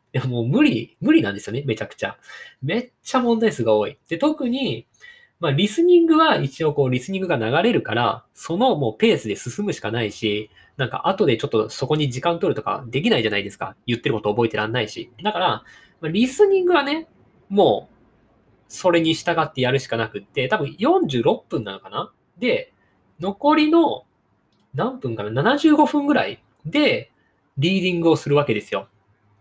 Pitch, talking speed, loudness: 165 Hz, 345 characters per minute, -21 LUFS